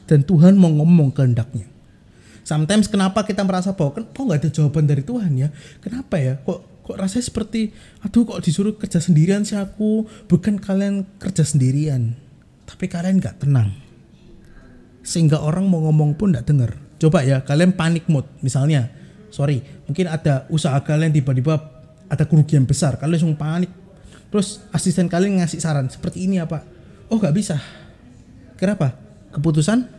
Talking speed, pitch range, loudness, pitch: 155 wpm, 145-190 Hz, -19 LUFS, 165 Hz